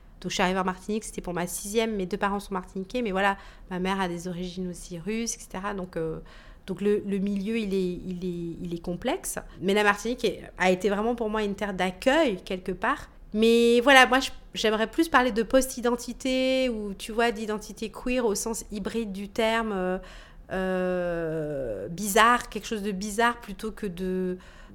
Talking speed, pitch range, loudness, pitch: 190 wpm, 185-230 Hz, -27 LUFS, 205 Hz